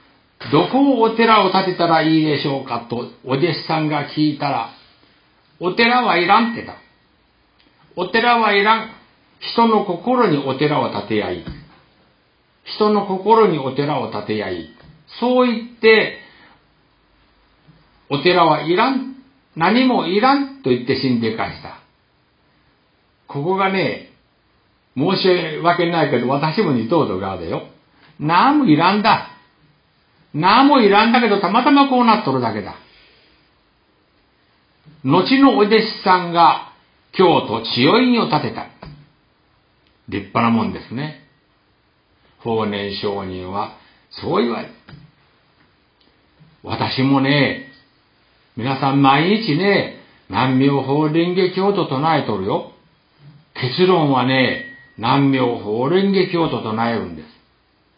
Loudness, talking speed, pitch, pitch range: -17 LUFS, 220 characters per minute, 155 Hz, 130-210 Hz